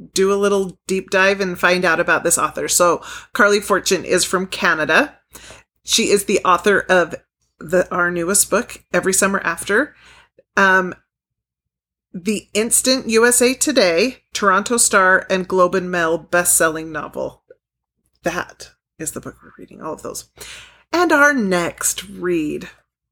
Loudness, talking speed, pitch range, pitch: -16 LUFS, 145 wpm, 180-225 Hz, 190 Hz